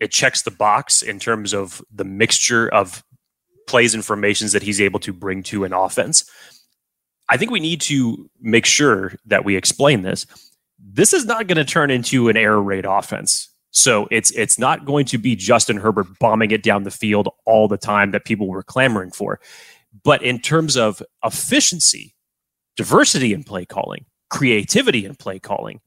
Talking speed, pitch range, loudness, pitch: 180 wpm, 100-130 Hz, -17 LUFS, 110 Hz